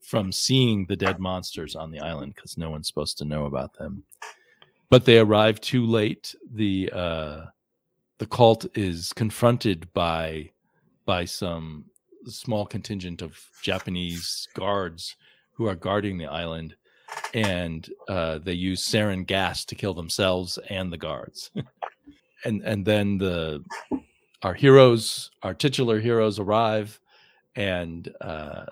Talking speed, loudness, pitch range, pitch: 135 wpm, -24 LUFS, 85-110 Hz, 95 Hz